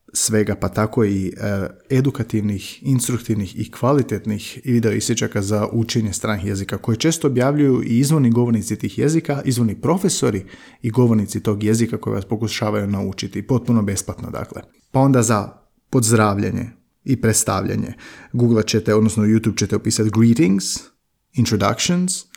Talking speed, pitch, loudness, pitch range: 135 wpm, 110 Hz, -19 LUFS, 105-120 Hz